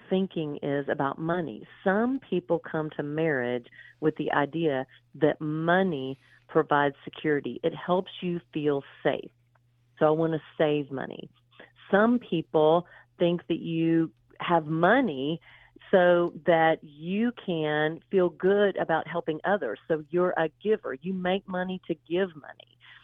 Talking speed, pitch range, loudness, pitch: 140 wpm, 150-180 Hz, -27 LUFS, 160 Hz